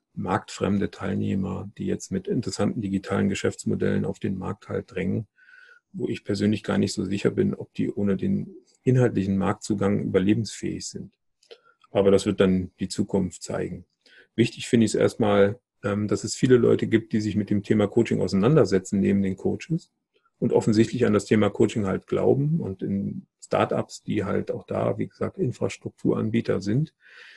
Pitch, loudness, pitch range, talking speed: 105 Hz, -25 LUFS, 100-120 Hz, 165 wpm